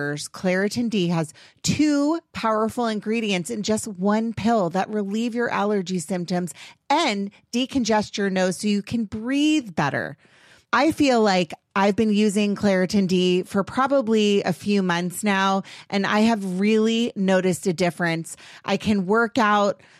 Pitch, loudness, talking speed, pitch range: 205 Hz, -22 LUFS, 145 wpm, 185-225 Hz